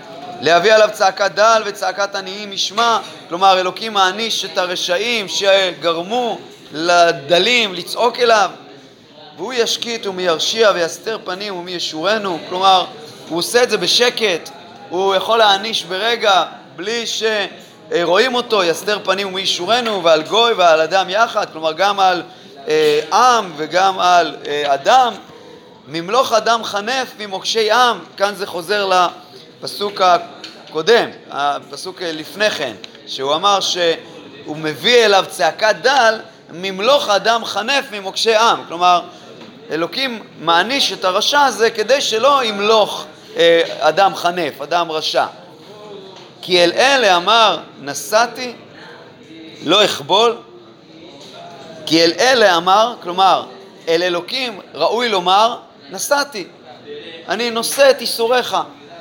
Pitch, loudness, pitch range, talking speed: 195 Hz, -15 LUFS, 175-225 Hz, 115 wpm